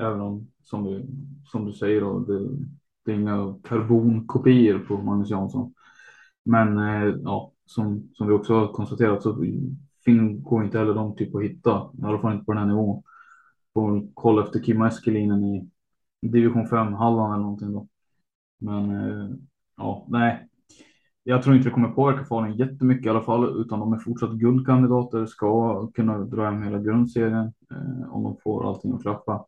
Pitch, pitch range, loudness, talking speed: 110 Hz, 105-120 Hz, -23 LUFS, 175 wpm